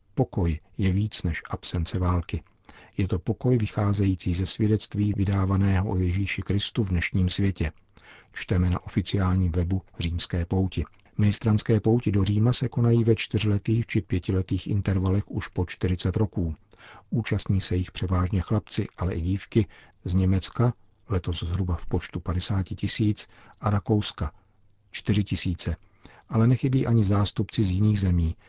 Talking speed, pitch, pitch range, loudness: 140 wpm, 100 Hz, 90-105 Hz, -25 LUFS